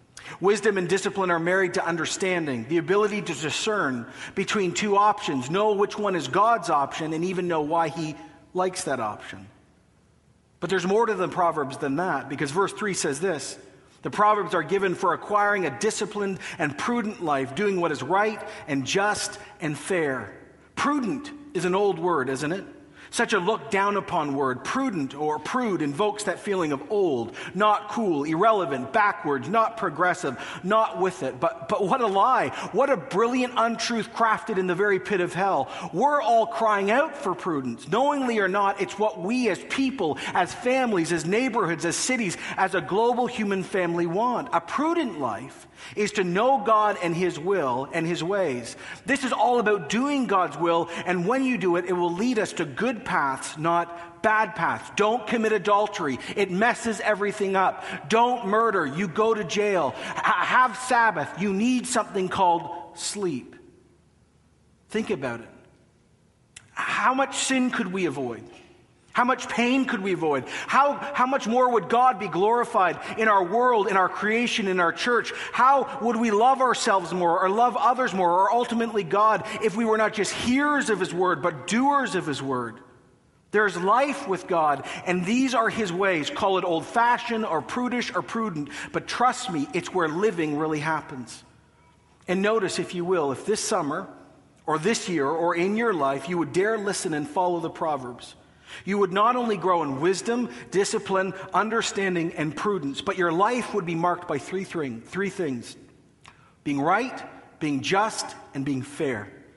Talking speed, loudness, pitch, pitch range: 175 wpm, -24 LUFS, 195 Hz, 170-225 Hz